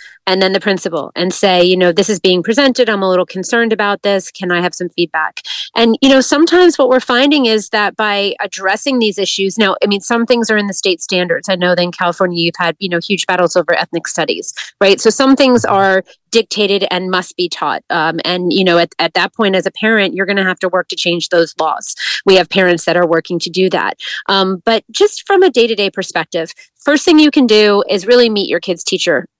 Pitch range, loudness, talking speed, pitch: 180-225 Hz, -12 LUFS, 245 wpm, 195 Hz